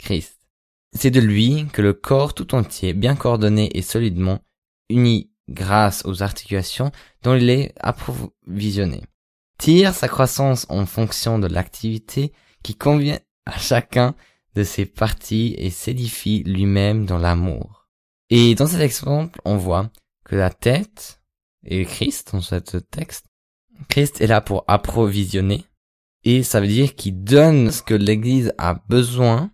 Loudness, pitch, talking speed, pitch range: -19 LUFS, 110 Hz, 140 wpm, 95-130 Hz